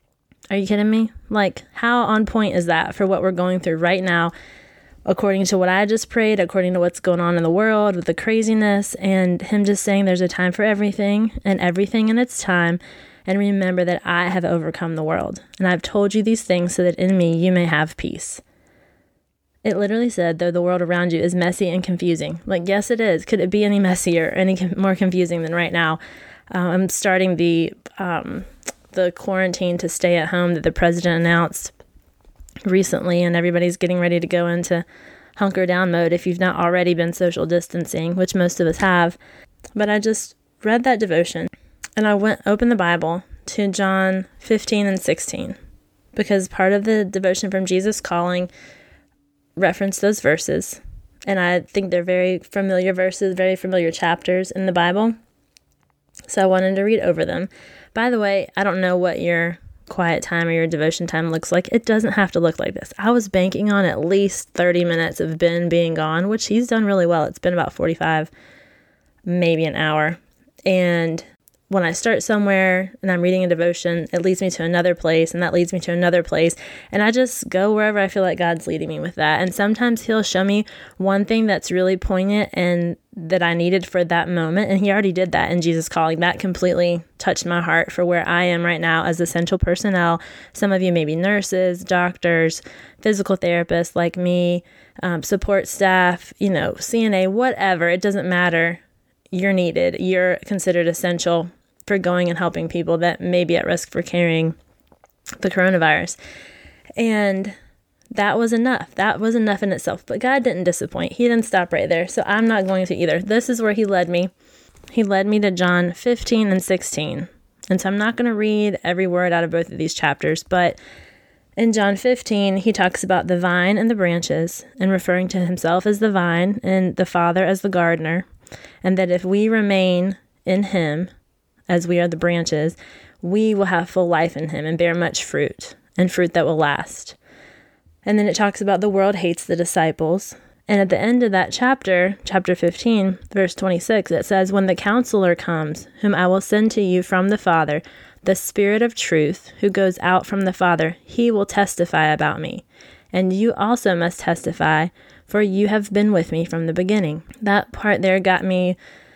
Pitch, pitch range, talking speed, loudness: 185 Hz, 175-200 Hz, 195 wpm, -19 LUFS